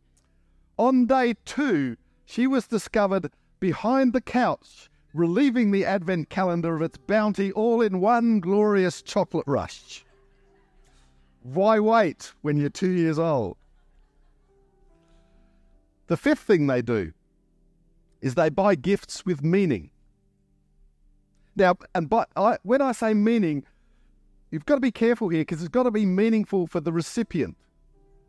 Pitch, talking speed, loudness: 175 Hz, 135 wpm, -24 LUFS